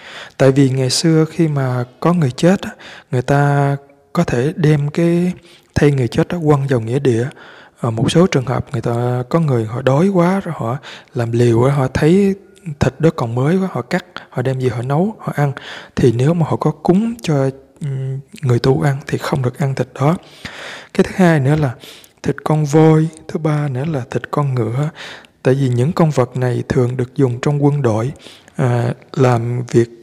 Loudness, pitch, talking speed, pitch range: -16 LUFS, 140 Hz, 200 wpm, 125-160 Hz